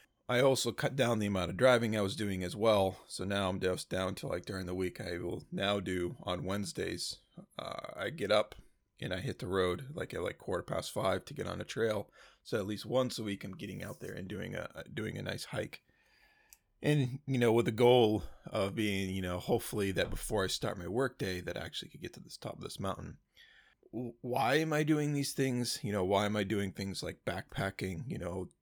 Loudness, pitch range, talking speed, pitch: -34 LUFS, 95-125 Hz, 235 wpm, 100 Hz